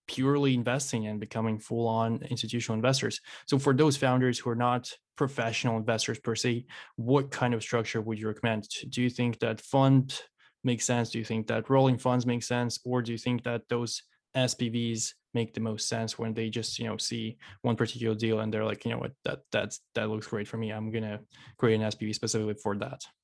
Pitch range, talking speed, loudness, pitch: 110-125 Hz, 210 wpm, -30 LUFS, 115 Hz